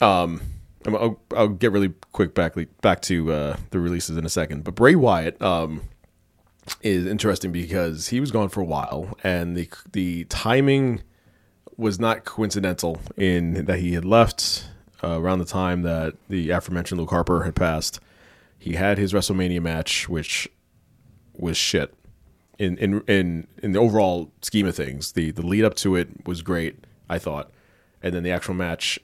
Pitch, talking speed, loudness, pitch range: 90 Hz, 170 wpm, -23 LUFS, 85-100 Hz